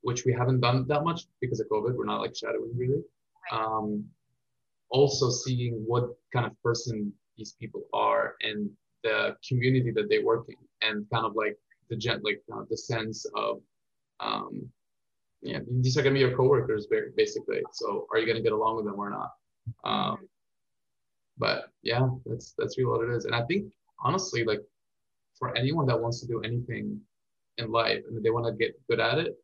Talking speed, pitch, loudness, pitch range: 200 wpm, 125 Hz, -29 LUFS, 115-170 Hz